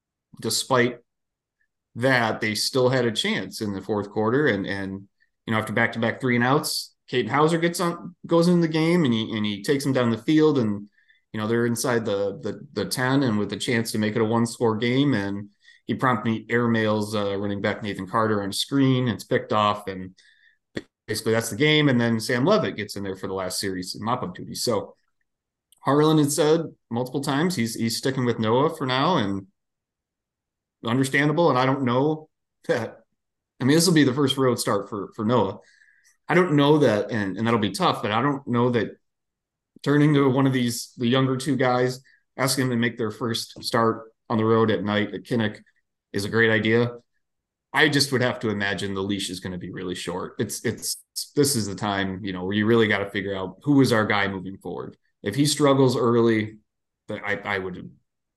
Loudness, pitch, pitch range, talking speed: -23 LUFS, 115 Hz, 105-135 Hz, 215 wpm